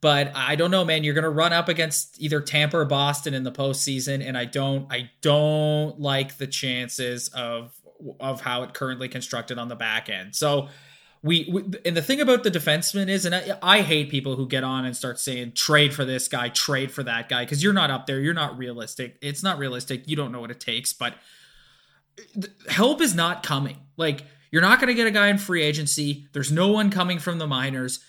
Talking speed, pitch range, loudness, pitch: 220 wpm, 130-165 Hz, -23 LUFS, 145 Hz